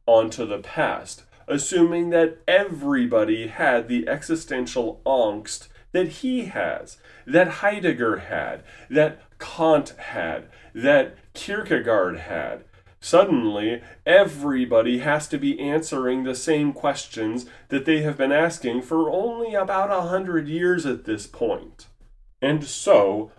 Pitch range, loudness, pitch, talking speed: 130-190 Hz, -22 LUFS, 155 Hz, 120 wpm